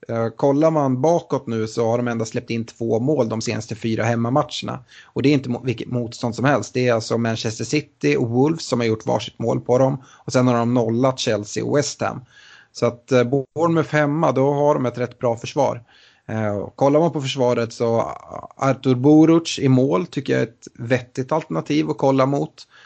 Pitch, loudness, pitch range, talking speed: 125 Hz, -20 LUFS, 115-145 Hz, 200 wpm